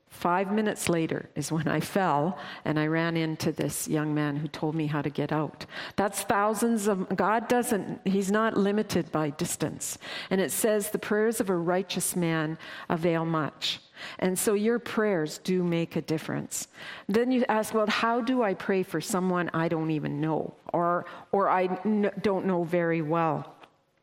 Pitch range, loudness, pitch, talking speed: 160-210 Hz, -28 LUFS, 180 Hz, 180 wpm